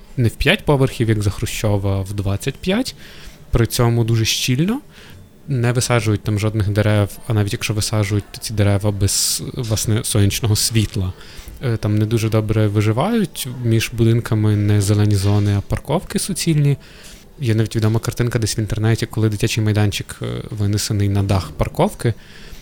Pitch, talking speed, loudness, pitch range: 110 Hz, 150 wpm, -18 LUFS, 105-120 Hz